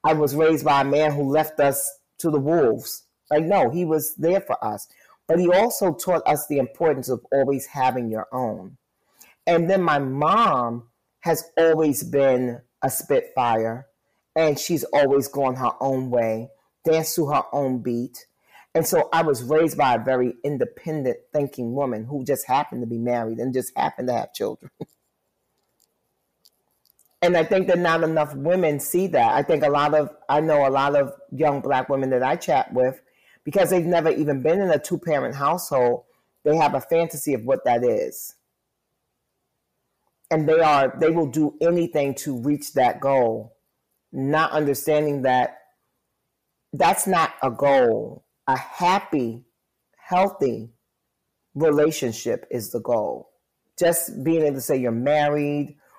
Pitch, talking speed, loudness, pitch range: 145 Hz, 160 wpm, -22 LUFS, 130-160 Hz